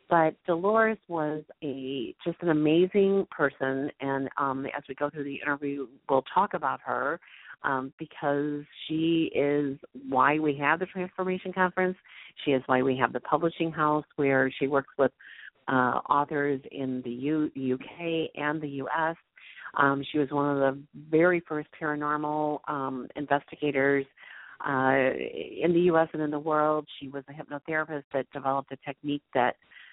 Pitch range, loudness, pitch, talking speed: 135-160 Hz, -28 LUFS, 145 Hz, 160 wpm